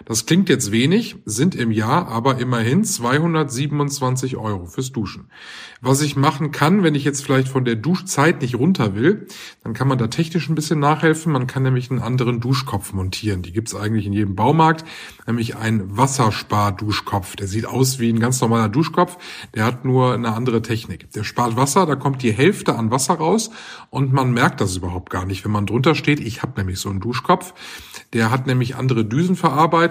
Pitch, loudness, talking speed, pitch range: 130 Hz, -19 LUFS, 200 wpm, 115-155 Hz